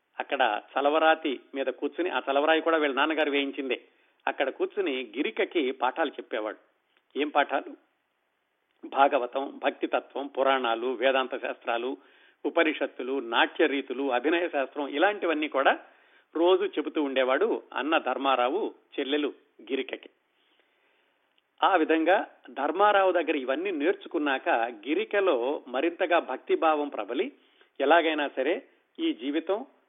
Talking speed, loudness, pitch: 100 wpm, -27 LUFS, 160 Hz